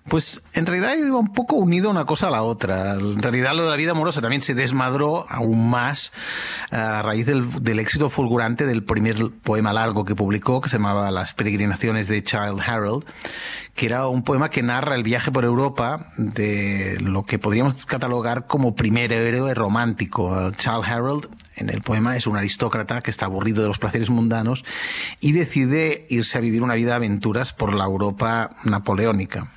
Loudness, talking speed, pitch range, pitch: -21 LUFS, 190 wpm, 110-135 Hz, 115 Hz